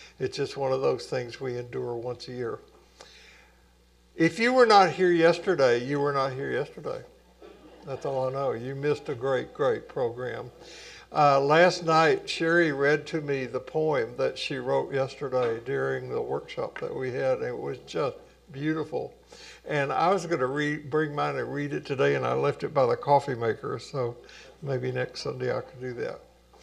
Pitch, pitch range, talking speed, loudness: 145 Hz, 130-180 Hz, 190 wpm, -27 LUFS